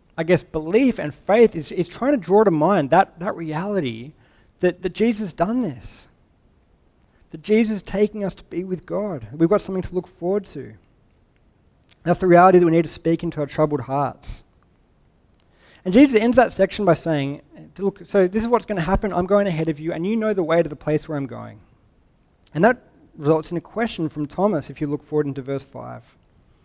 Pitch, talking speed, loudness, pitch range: 170 Hz, 215 wpm, -20 LUFS, 145-195 Hz